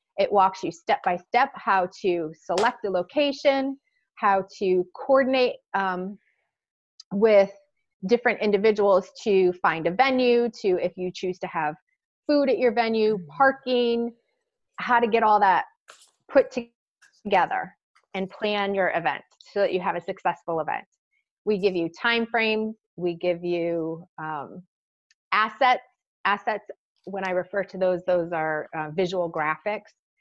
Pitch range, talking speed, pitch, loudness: 180-240 Hz, 145 wpm, 200 Hz, -24 LUFS